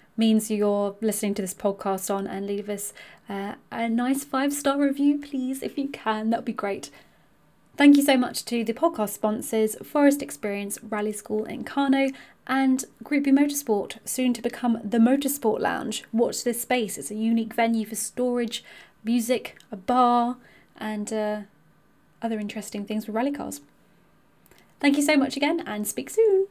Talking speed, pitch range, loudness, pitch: 170 wpm, 215-270 Hz, -25 LUFS, 230 Hz